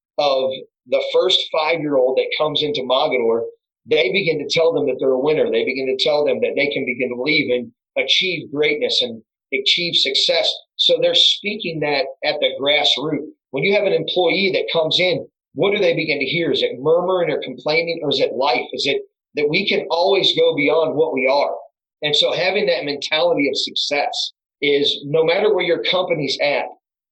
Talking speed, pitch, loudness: 200 wpm, 205 Hz, -18 LUFS